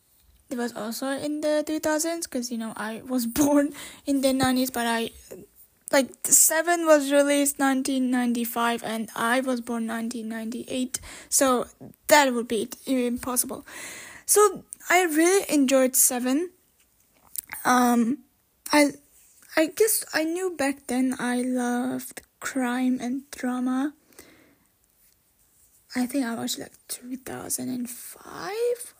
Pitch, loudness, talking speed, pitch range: 260 Hz, -24 LUFS, 130 wpm, 245-295 Hz